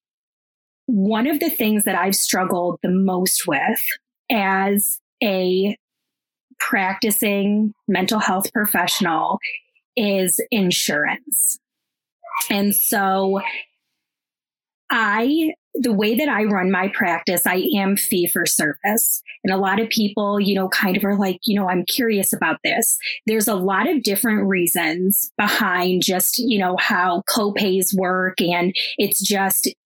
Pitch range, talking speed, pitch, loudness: 190-230 Hz, 135 wpm, 205 Hz, -19 LUFS